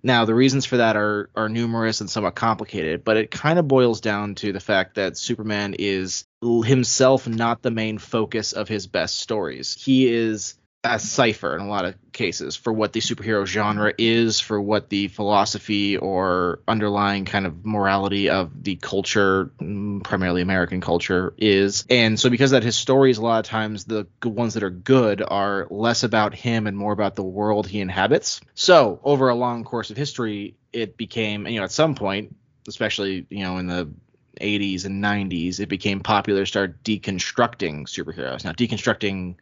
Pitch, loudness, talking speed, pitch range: 105 Hz, -21 LUFS, 185 wpm, 100-115 Hz